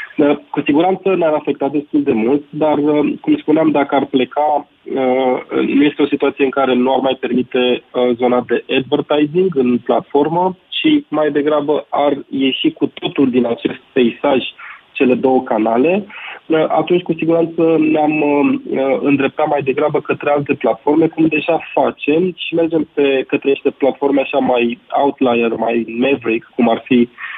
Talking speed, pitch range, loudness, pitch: 150 wpm, 130-155 Hz, -15 LUFS, 145 Hz